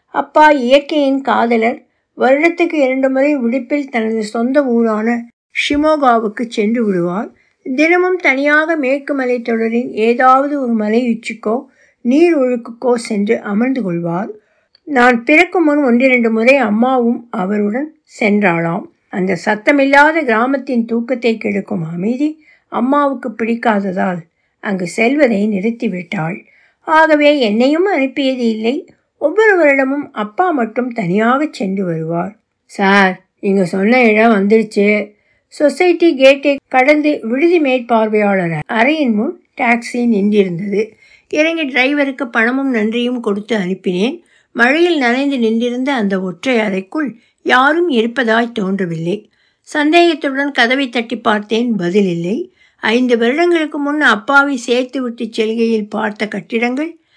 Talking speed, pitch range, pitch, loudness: 105 wpm, 215-280 Hz, 240 Hz, -14 LUFS